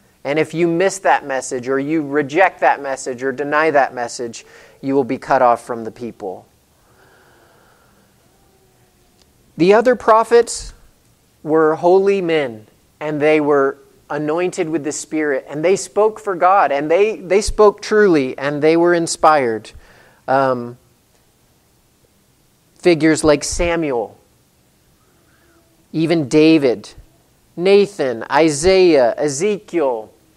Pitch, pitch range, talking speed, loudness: 155 Hz, 135-180 Hz, 115 wpm, -16 LUFS